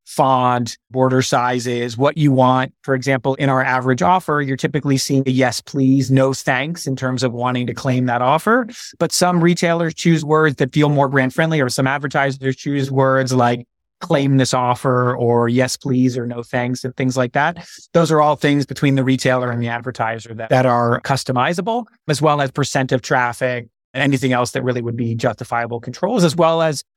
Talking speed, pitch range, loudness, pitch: 200 wpm, 125-145 Hz, -17 LUFS, 130 Hz